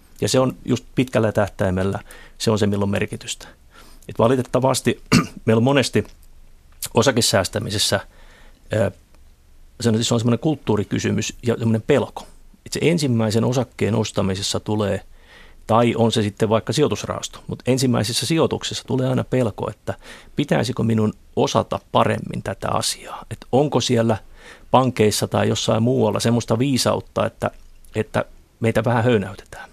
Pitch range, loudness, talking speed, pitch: 100-120 Hz, -20 LUFS, 125 wpm, 110 Hz